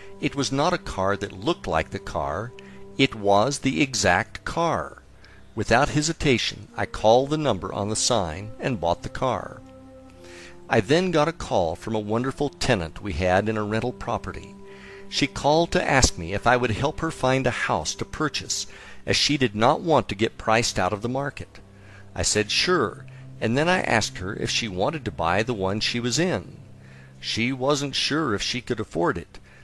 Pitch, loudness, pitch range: 110 Hz, -24 LUFS, 95-135 Hz